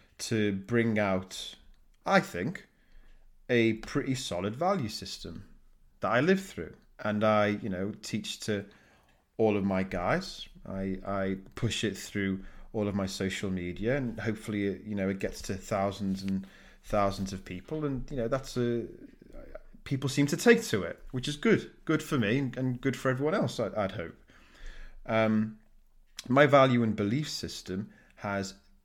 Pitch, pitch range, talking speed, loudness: 105 Hz, 95-125 Hz, 160 wpm, -30 LUFS